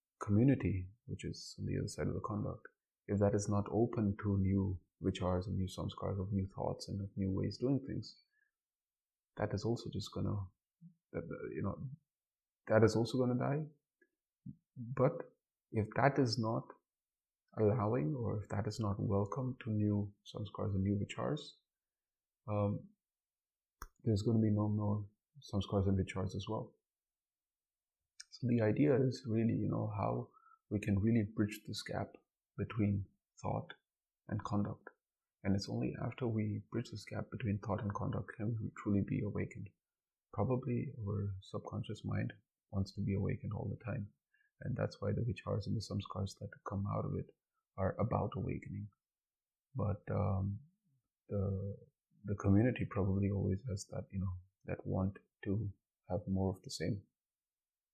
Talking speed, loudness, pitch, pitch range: 160 wpm, -38 LUFS, 105 Hz, 100-120 Hz